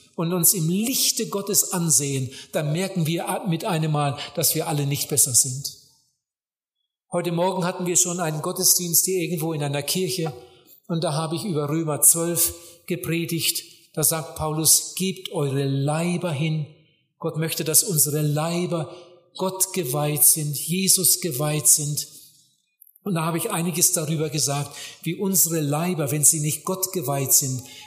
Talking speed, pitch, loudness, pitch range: 155 wpm, 165 Hz, -21 LUFS, 150-180 Hz